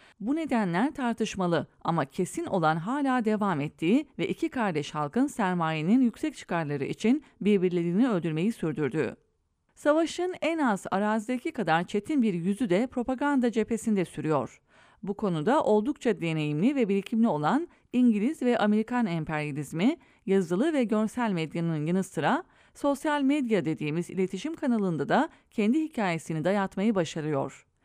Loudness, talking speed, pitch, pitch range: -28 LUFS, 125 wpm, 210 Hz, 170-255 Hz